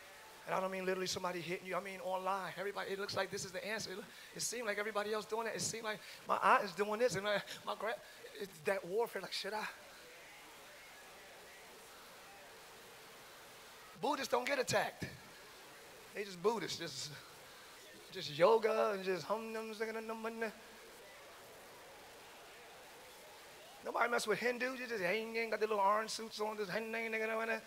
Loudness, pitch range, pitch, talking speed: -38 LUFS, 195-225 Hz, 210 Hz, 160 wpm